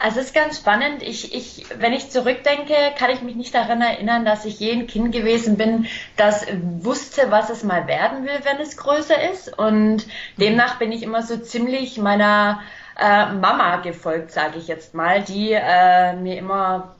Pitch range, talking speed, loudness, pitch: 205-250 Hz, 185 wpm, -19 LUFS, 225 Hz